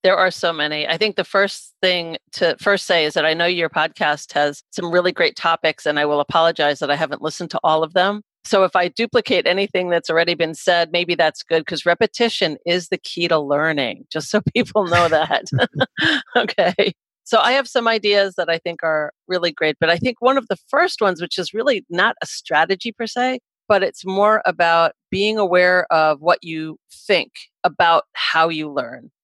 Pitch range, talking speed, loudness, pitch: 160-200 Hz, 205 wpm, -18 LUFS, 175 Hz